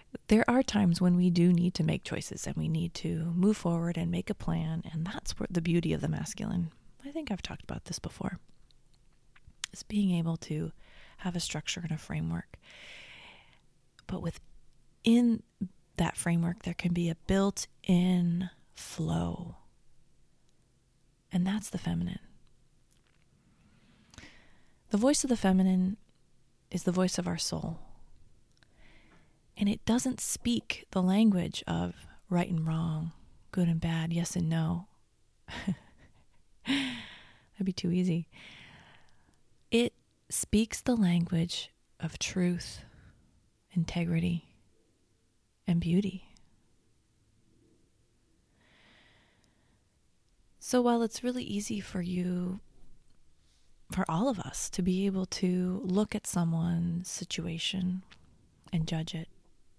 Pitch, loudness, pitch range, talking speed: 170 Hz, -31 LUFS, 145-190 Hz, 120 wpm